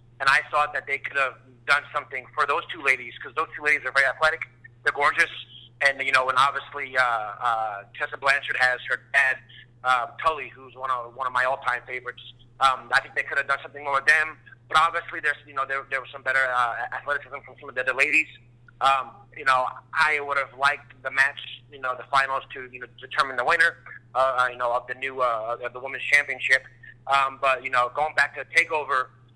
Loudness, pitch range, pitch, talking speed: -24 LUFS, 125-140 Hz, 130 Hz, 225 wpm